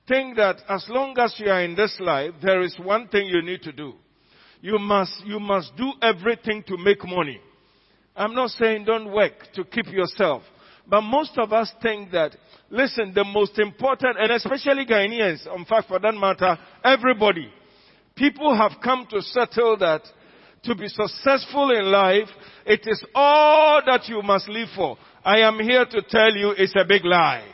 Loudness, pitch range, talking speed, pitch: -21 LUFS, 195-235 Hz, 180 wpm, 210 Hz